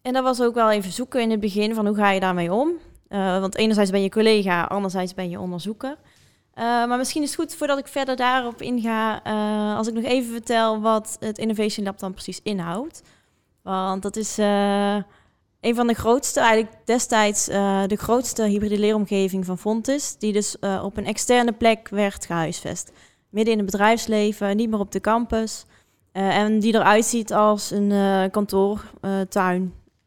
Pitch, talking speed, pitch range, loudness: 215 Hz, 190 wpm, 200-230 Hz, -22 LUFS